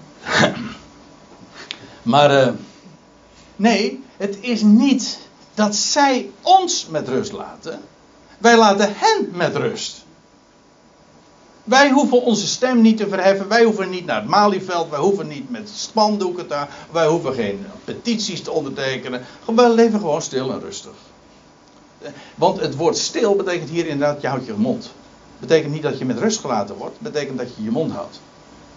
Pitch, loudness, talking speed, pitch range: 205 Hz, -18 LUFS, 150 wpm, 160-230 Hz